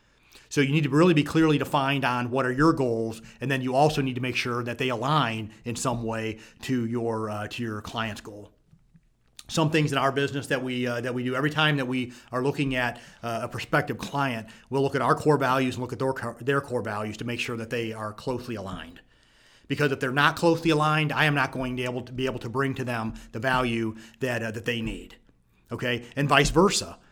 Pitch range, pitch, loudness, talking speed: 115-140 Hz, 125 Hz, -26 LUFS, 235 wpm